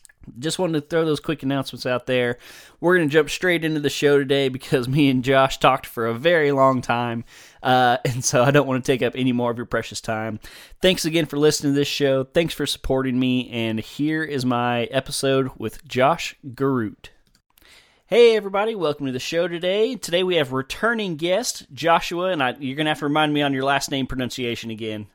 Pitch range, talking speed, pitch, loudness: 125-155 Hz, 215 wpm, 135 Hz, -21 LUFS